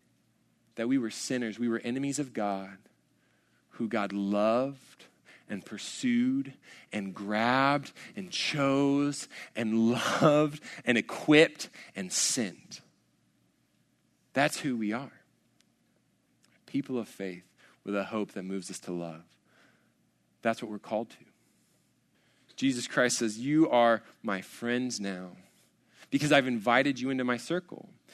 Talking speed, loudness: 125 wpm, -30 LUFS